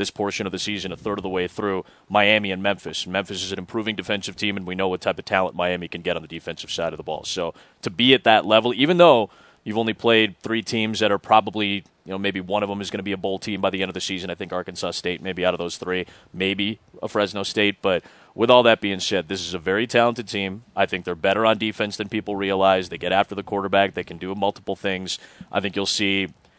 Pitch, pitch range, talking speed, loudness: 100 Hz, 95-110 Hz, 270 wpm, -22 LUFS